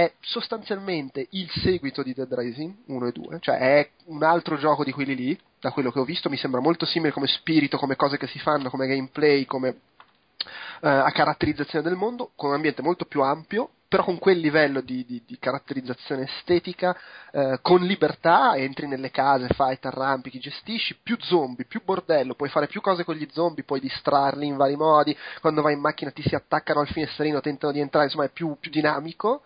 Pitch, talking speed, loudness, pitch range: 150 Hz, 205 wpm, -24 LUFS, 140-170 Hz